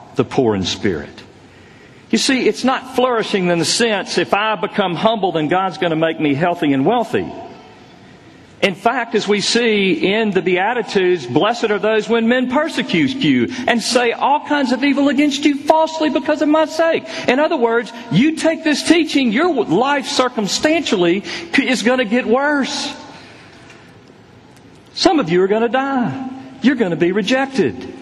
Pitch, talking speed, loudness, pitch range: 245 Hz, 170 wpm, -16 LUFS, 205-285 Hz